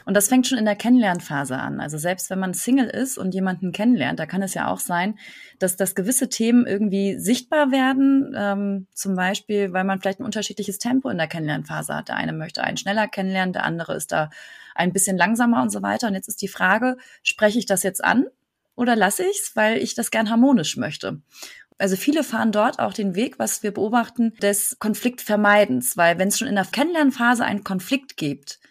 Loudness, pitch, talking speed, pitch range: -21 LUFS, 210 Hz, 210 wpm, 190-245 Hz